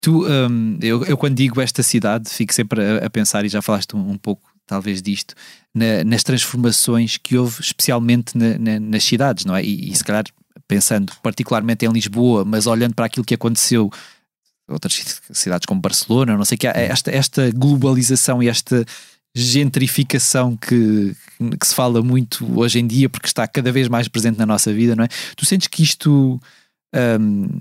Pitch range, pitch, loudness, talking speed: 110-130 Hz, 120 Hz, -17 LUFS, 185 wpm